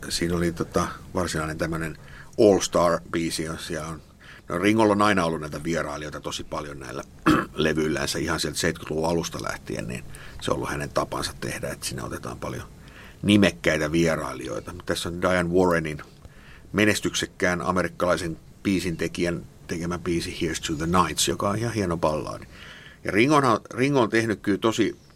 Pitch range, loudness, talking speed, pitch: 80-100 Hz, -25 LUFS, 145 wpm, 85 Hz